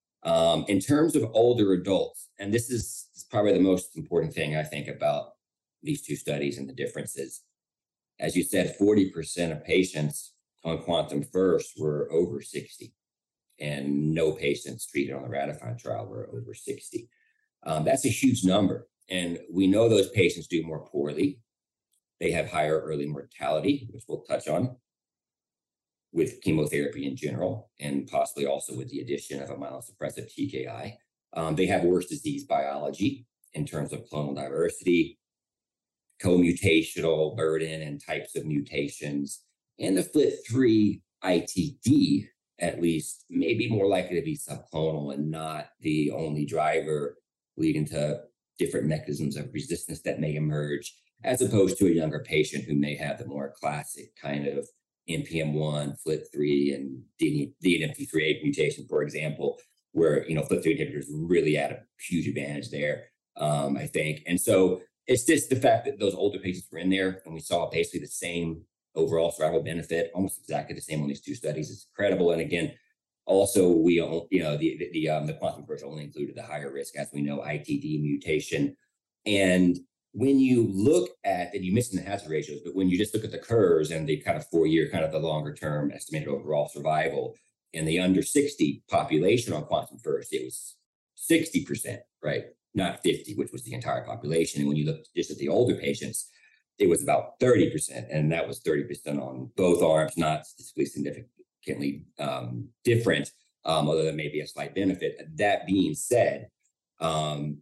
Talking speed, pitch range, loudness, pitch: 170 wpm, 75-100 Hz, -28 LUFS, 80 Hz